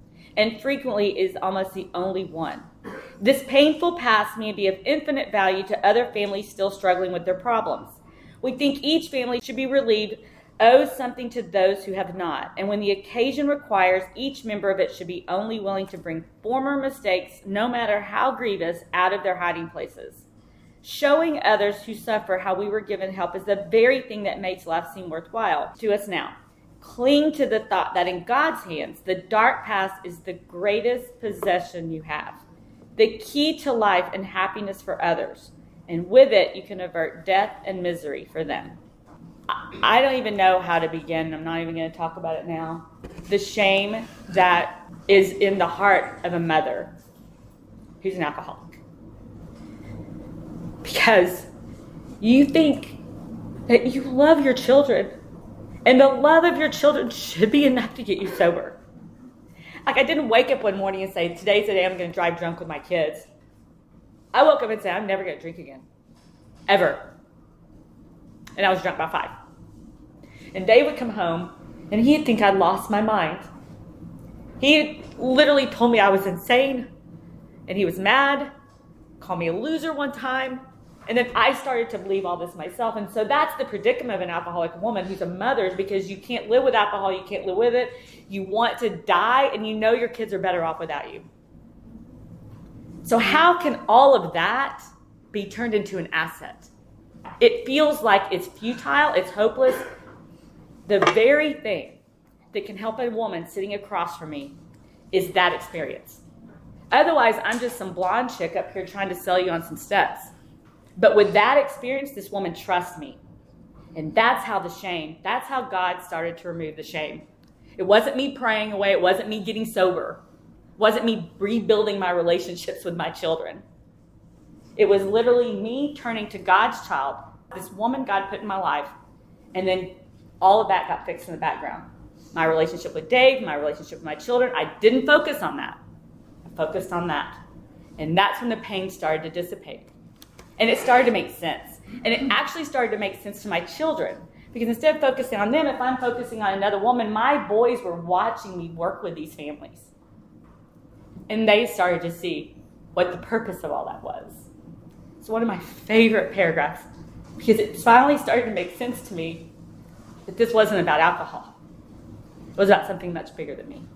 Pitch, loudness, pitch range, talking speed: 200 Hz, -22 LUFS, 180-245 Hz, 180 wpm